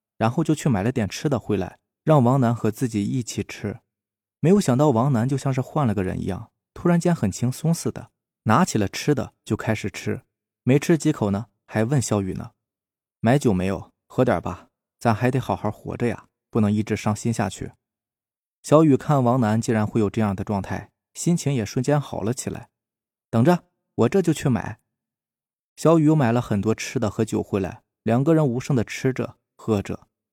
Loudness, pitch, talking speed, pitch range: -23 LUFS, 115 Hz, 275 characters per minute, 105-135 Hz